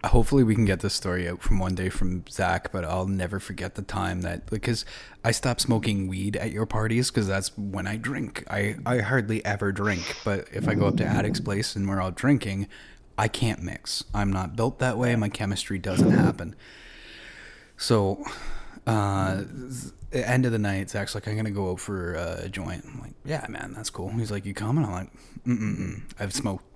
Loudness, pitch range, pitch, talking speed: -27 LUFS, 95-115 Hz, 100 Hz, 205 wpm